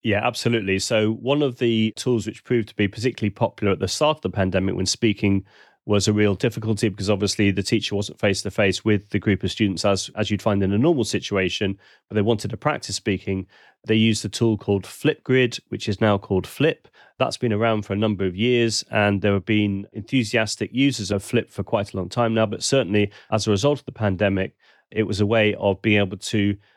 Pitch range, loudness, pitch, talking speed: 100-115 Hz, -22 LUFS, 105 Hz, 225 wpm